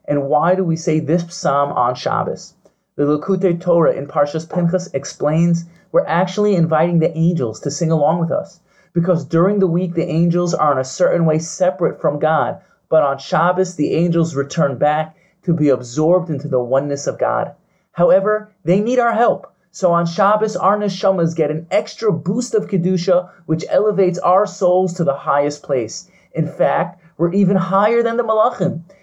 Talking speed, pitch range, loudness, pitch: 180 wpm, 160-190 Hz, -17 LUFS, 175 Hz